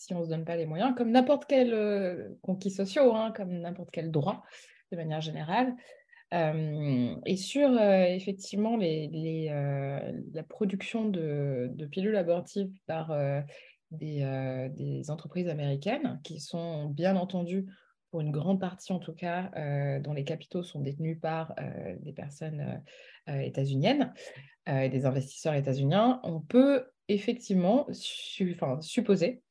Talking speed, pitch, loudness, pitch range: 155 wpm, 170 Hz, -31 LUFS, 150-200 Hz